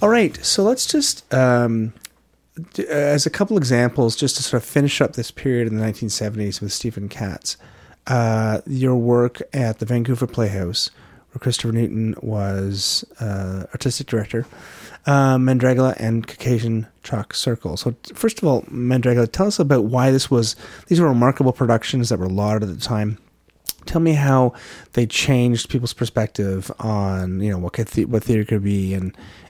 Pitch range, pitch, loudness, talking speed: 105-130 Hz, 120 Hz, -20 LUFS, 175 wpm